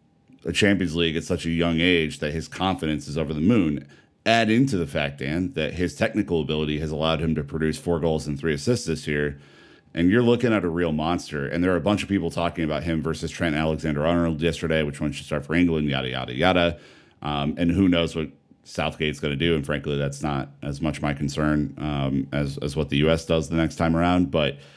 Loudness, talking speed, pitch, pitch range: -24 LUFS, 235 wpm, 80 Hz, 75-85 Hz